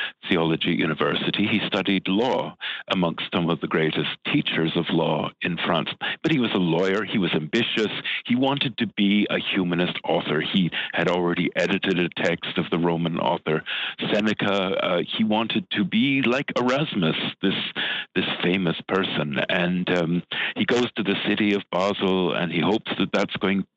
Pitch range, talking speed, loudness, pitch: 85-105 Hz, 170 wpm, -23 LUFS, 95 Hz